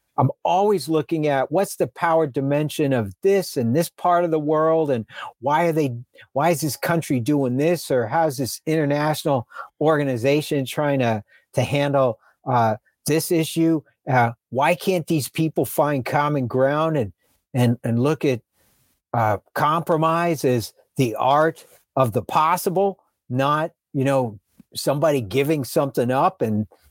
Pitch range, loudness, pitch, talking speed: 130-160 Hz, -21 LUFS, 145 Hz, 150 wpm